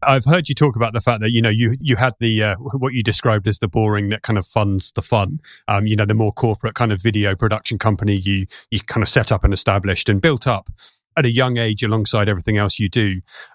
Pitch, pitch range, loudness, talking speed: 110 Hz, 105-120 Hz, -18 LUFS, 255 wpm